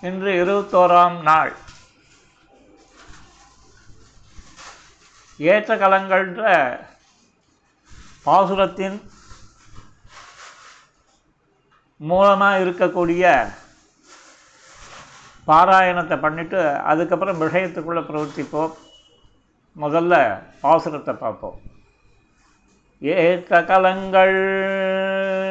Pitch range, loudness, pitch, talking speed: 155-190 Hz, -18 LUFS, 180 Hz, 40 wpm